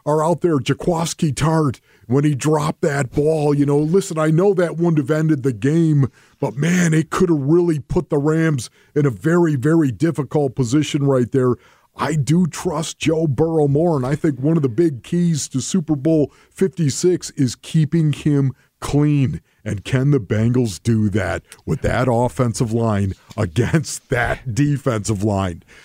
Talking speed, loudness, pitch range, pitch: 170 wpm, -19 LUFS, 130-160 Hz, 150 Hz